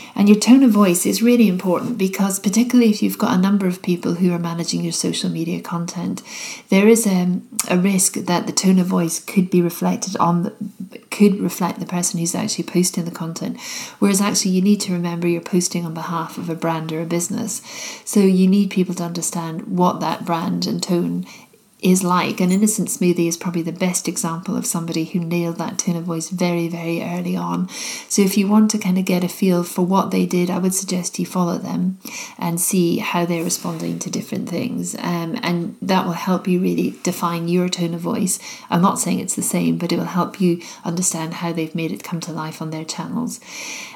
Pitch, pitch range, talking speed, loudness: 180 Hz, 170-200 Hz, 215 wpm, -19 LUFS